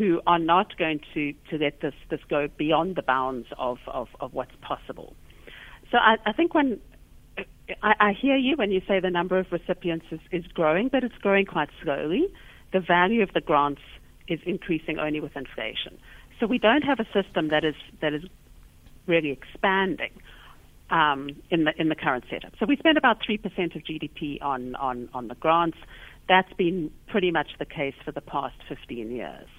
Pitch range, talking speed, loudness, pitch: 150-195 Hz, 190 wpm, -25 LUFS, 170 Hz